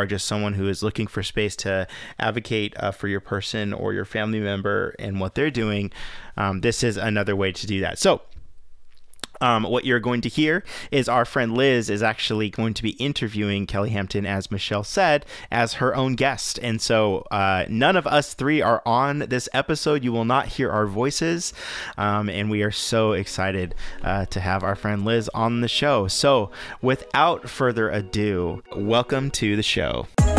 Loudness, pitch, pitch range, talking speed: -23 LUFS, 110 Hz, 100-120 Hz, 190 wpm